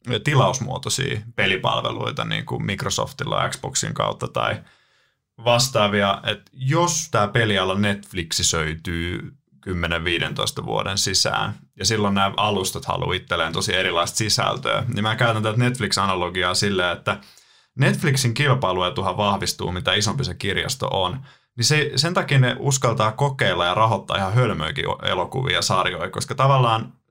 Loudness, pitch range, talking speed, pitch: -21 LUFS, 100-130 Hz, 130 wpm, 110 Hz